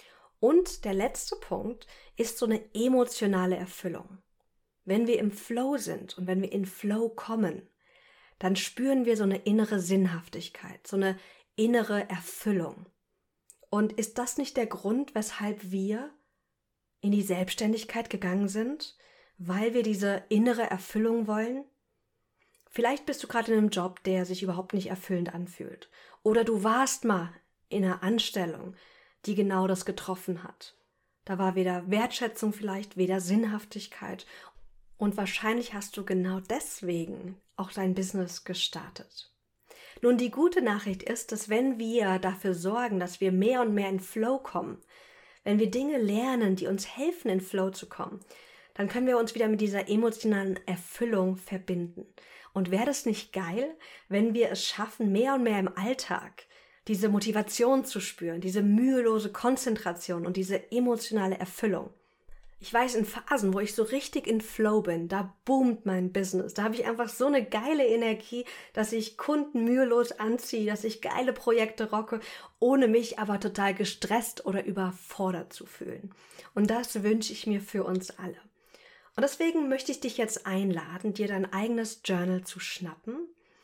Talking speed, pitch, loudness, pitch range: 155 wpm, 215 Hz, -29 LUFS, 190-235 Hz